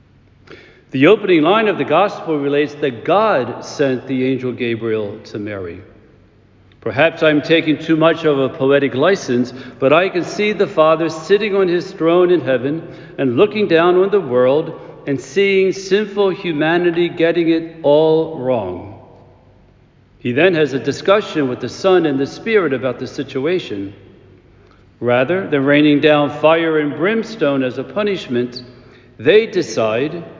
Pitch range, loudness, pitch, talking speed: 125-175 Hz, -16 LUFS, 150 Hz, 150 wpm